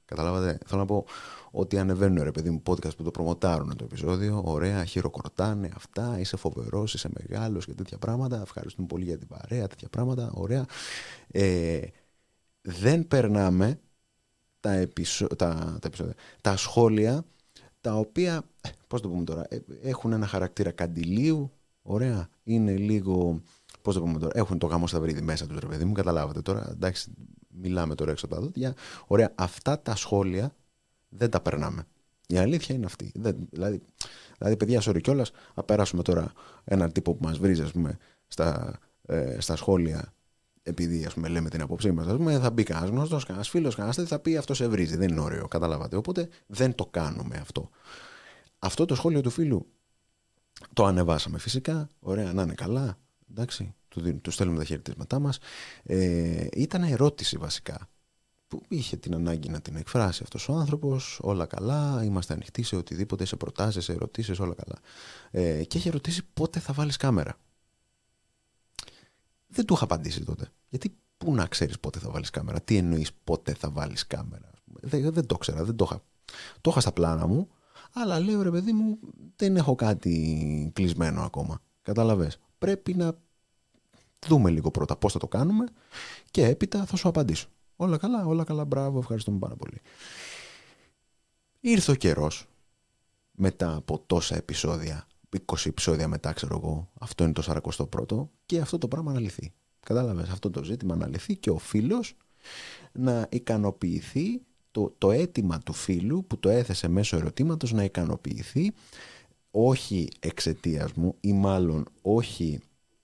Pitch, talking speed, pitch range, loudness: 100 Hz, 160 wpm, 85-130 Hz, -28 LUFS